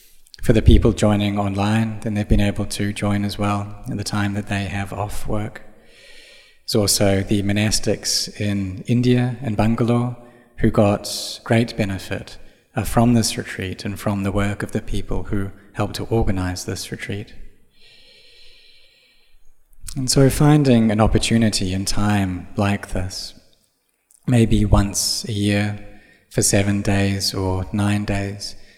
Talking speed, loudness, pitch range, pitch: 140 wpm, -20 LUFS, 100-115 Hz, 105 Hz